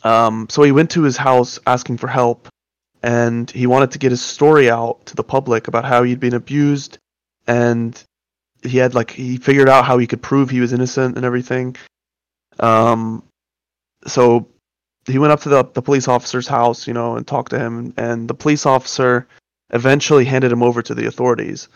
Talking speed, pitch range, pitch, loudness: 195 wpm, 115-130 Hz, 125 Hz, -15 LUFS